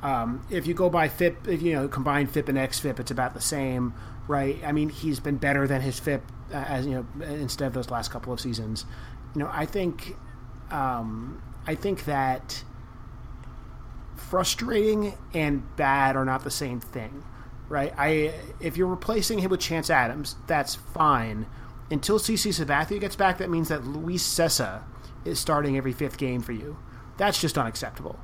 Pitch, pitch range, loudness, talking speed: 140 Hz, 125-160 Hz, -27 LUFS, 180 wpm